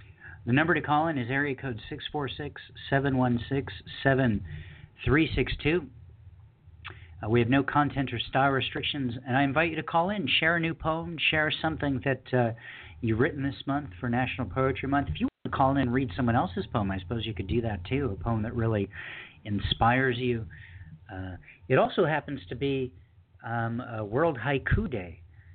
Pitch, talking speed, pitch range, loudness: 125 Hz, 180 wpm, 110-140 Hz, -28 LUFS